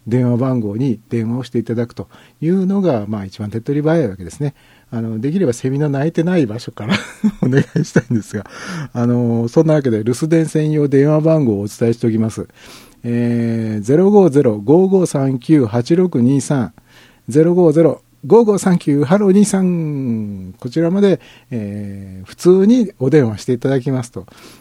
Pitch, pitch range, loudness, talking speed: 135 Hz, 115-165 Hz, -15 LUFS, 280 characters per minute